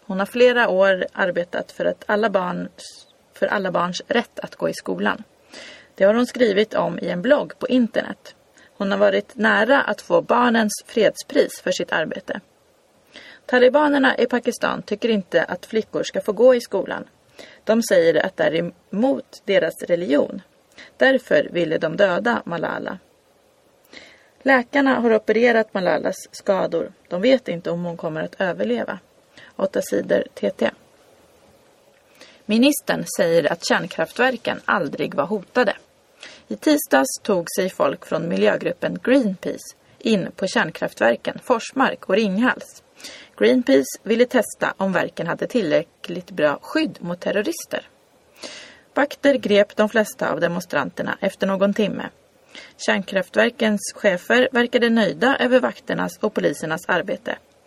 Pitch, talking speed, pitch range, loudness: 225 Hz, 135 wpm, 195-265 Hz, -20 LUFS